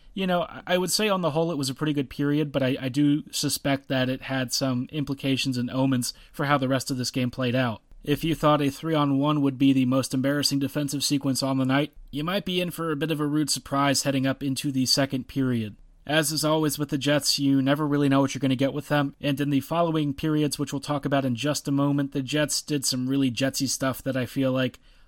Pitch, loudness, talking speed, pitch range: 140 Hz, -25 LUFS, 265 wpm, 135-150 Hz